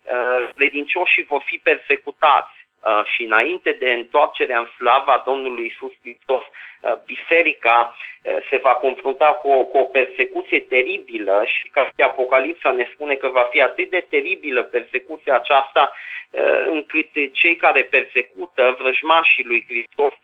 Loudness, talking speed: -18 LUFS, 130 wpm